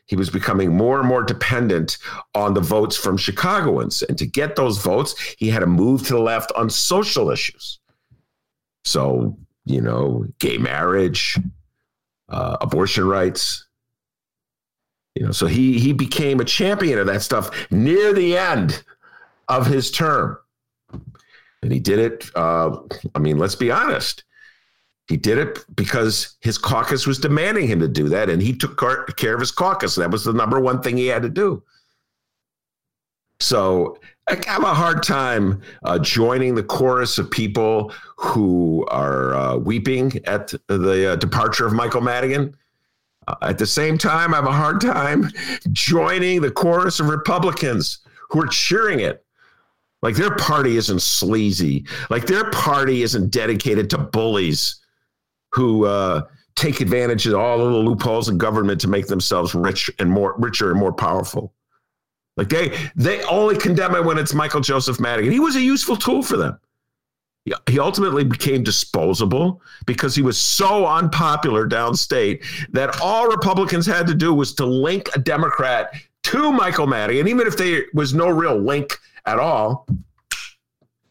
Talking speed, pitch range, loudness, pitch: 160 wpm, 100-155 Hz, -19 LUFS, 125 Hz